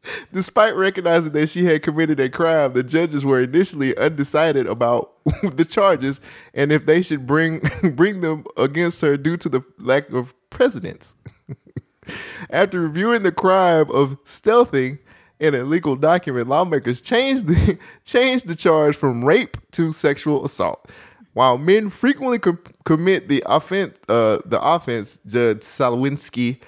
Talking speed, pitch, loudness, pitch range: 145 wpm, 155 Hz, -19 LUFS, 135-180 Hz